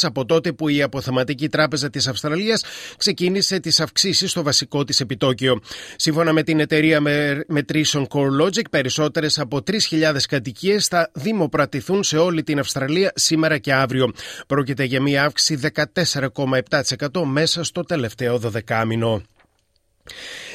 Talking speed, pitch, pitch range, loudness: 125 wpm, 150 Hz, 135-165 Hz, -19 LUFS